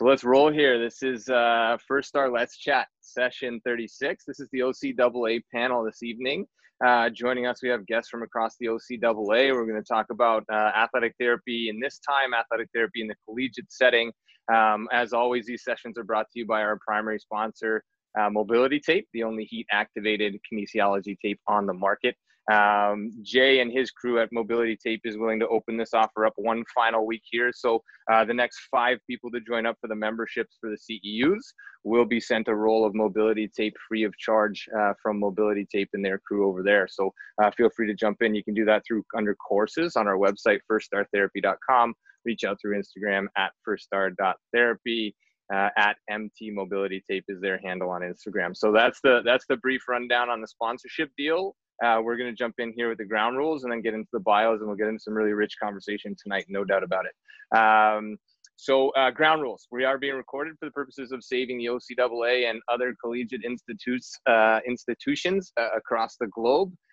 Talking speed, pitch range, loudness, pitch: 205 wpm, 105-120 Hz, -25 LUFS, 115 Hz